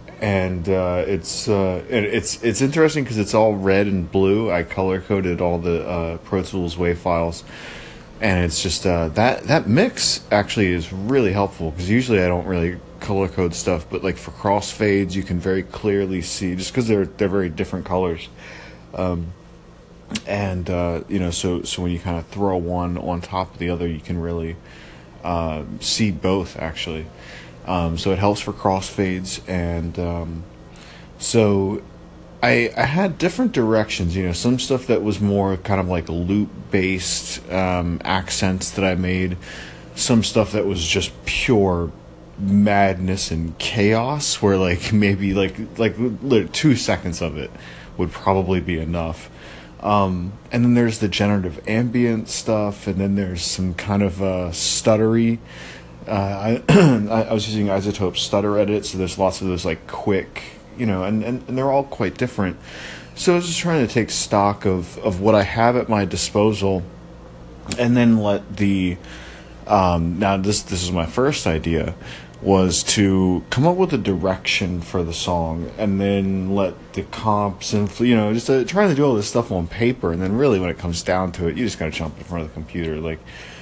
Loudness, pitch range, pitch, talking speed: -20 LUFS, 85-105 Hz, 95 Hz, 180 wpm